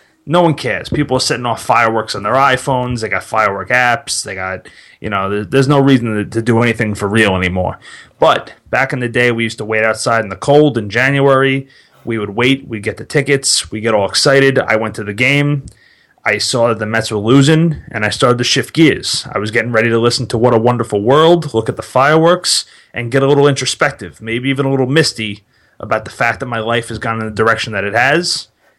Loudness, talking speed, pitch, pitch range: -13 LUFS, 235 wpm, 120 Hz, 110-135 Hz